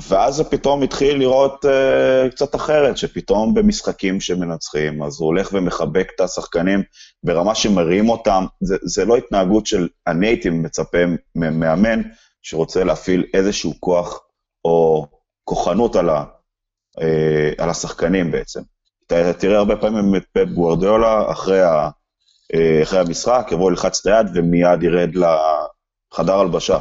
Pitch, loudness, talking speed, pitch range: 90 Hz, -17 LUFS, 130 wpm, 85-110 Hz